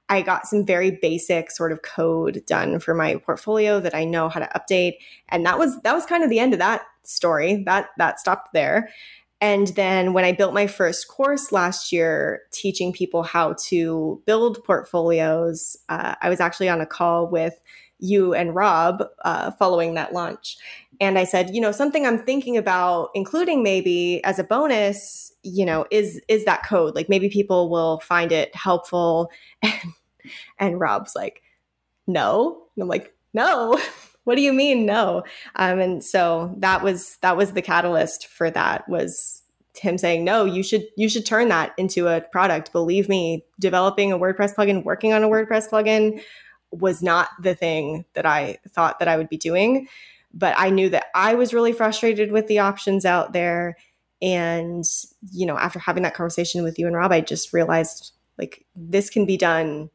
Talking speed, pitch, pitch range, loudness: 185 wpm, 185 Hz, 170-210 Hz, -21 LUFS